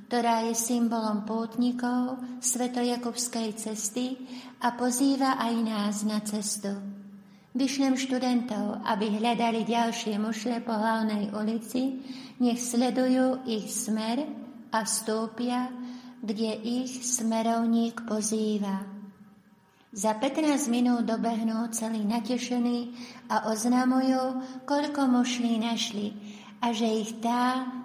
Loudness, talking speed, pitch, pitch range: -28 LUFS, 100 wpm, 235 Hz, 220-250 Hz